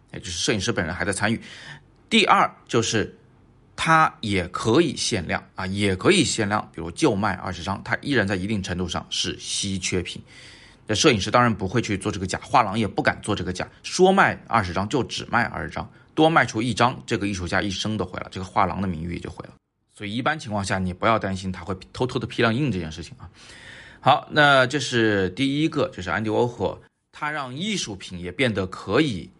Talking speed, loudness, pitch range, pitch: 325 characters per minute, -23 LUFS, 95-120 Hz, 105 Hz